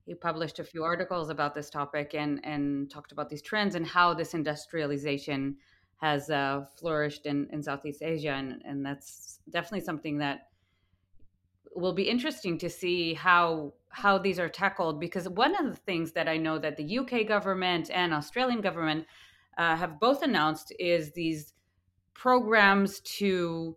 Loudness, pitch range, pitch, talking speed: -29 LUFS, 145-180 Hz, 160 Hz, 160 wpm